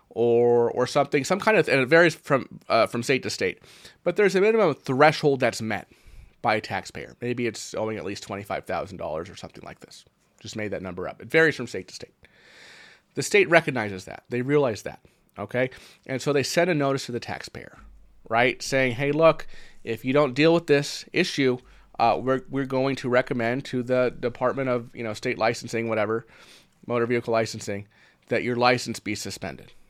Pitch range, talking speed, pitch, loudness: 115-145 Hz, 200 wpm, 125 Hz, -24 LUFS